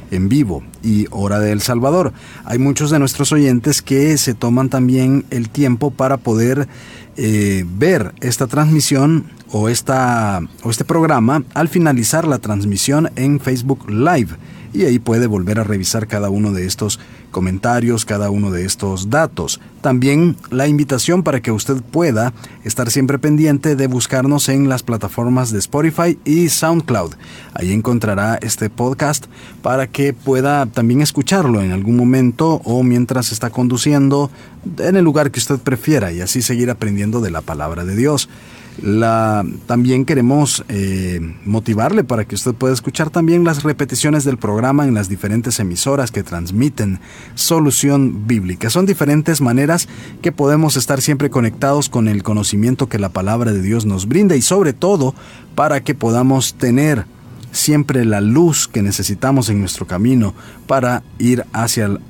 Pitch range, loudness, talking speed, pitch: 110-140 Hz, -15 LUFS, 155 wpm, 125 Hz